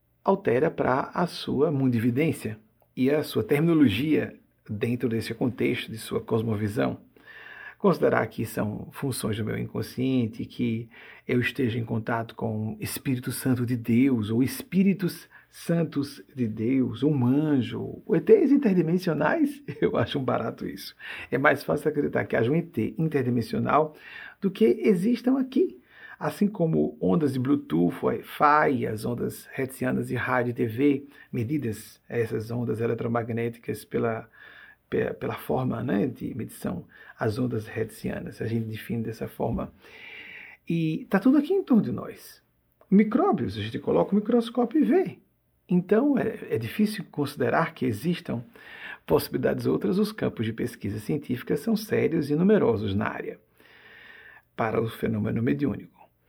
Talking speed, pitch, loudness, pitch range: 140 wpm, 135 Hz, -26 LUFS, 115-195 Hz